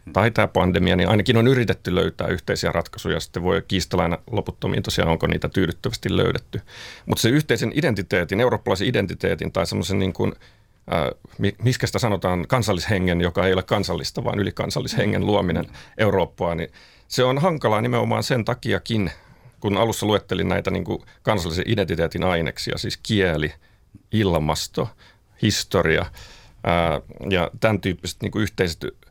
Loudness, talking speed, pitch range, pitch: -22 LUFS, 140 wpm, 90-115 Hz, 100 Hz